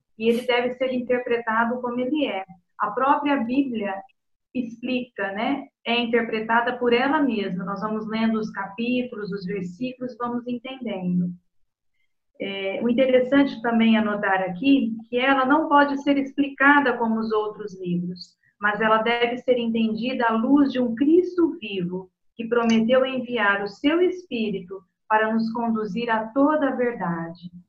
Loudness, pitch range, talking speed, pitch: -23 LUFS, 210-255 Hz, 145 wpm, 235 Hz